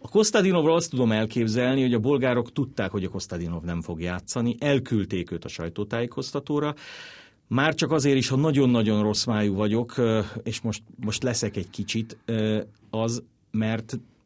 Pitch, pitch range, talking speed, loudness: 115 Hz, 105-130 Hz, 150 wpm, -25 LUFS